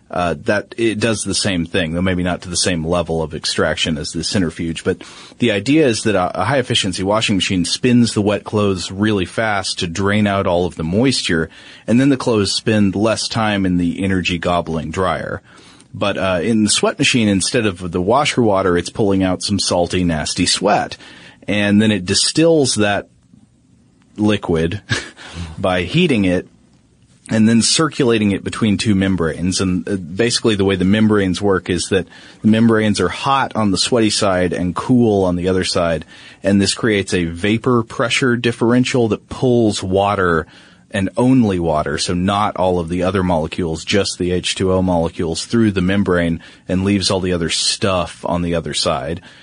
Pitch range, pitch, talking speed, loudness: 90-110 Hz, 95 Hz, 180 wpm, -16 LUFS